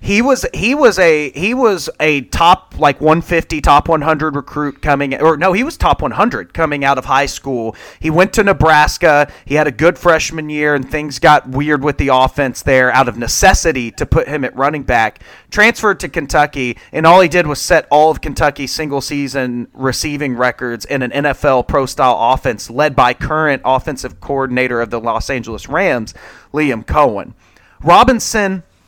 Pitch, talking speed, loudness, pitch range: 145 Hz, 180 wpm, -13 LUFS, 130-160 Hz